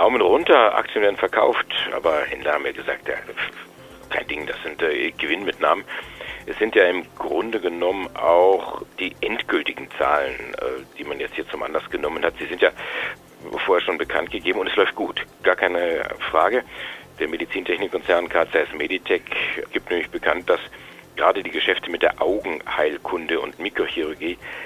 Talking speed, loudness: 160 wpm, -22 LUFS